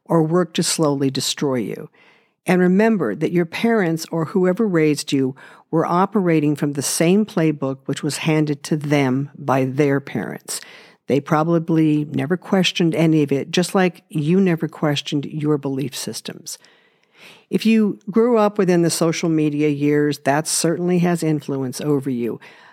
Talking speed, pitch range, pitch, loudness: 155 wpm, 145-180 Hz, 160 Hz, -19 LUFS